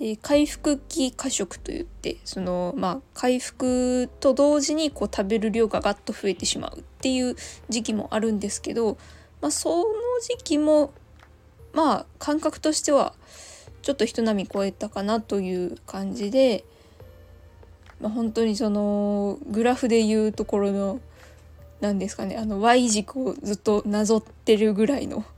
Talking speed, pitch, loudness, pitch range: 285 characters per minute, 225 Hz, -24 LUFS, 205-275 Hz